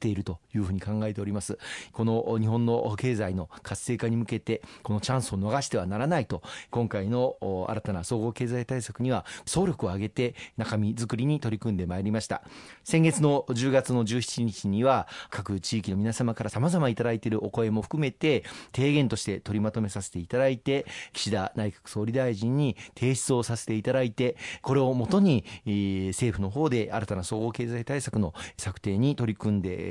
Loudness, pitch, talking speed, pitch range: -28 LUFS, 115 Hz, 335 characters per minute, 105-125 Hz